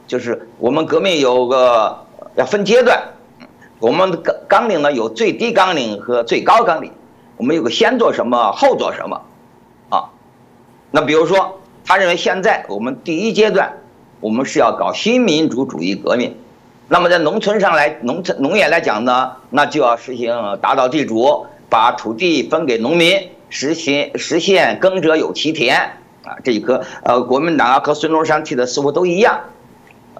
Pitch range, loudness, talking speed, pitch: 130-190 Hz, -15 LUFS, 250 characters per minute, 155 Hz